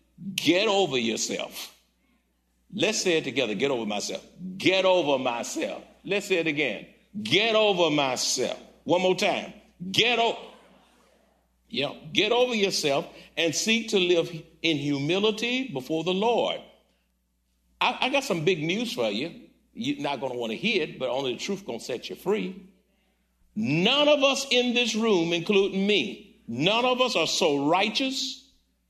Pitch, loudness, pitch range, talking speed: 190 Hz, -25 LUFS, 160-220 Hz, 160 wpm